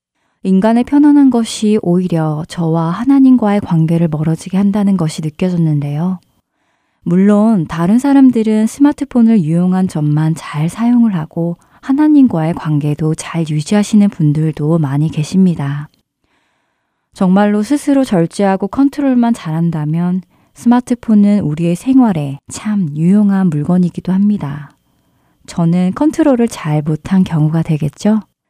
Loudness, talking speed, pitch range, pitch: -13 LUFS, 295 characters per minute, 160-225 Hz, 185 Hz